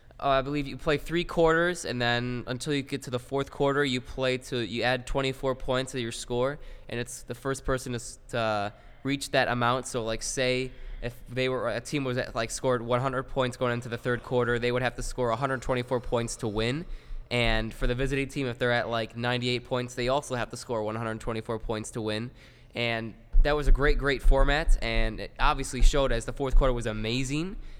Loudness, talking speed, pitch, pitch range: -29 LUFS, 215 wpm, 125 Hz, 120-135 Hz